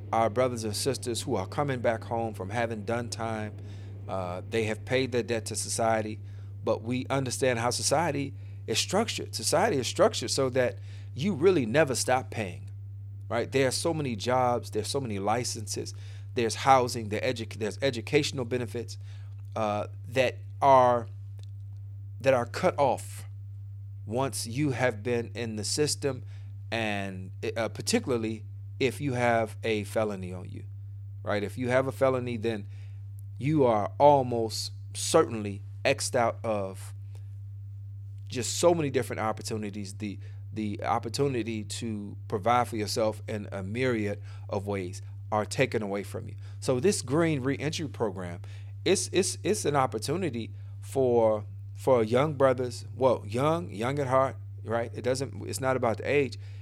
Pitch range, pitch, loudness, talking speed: 100-125 Hz, 110 Hz, -29 LUFS, 150 wpm